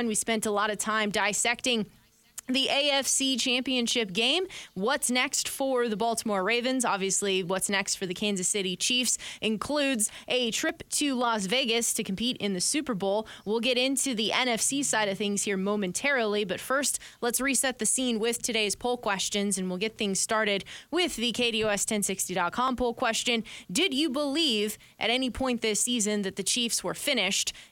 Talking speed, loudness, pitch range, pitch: 175 wpm, -27 LUFS, 205-255 Hz, 230 Hz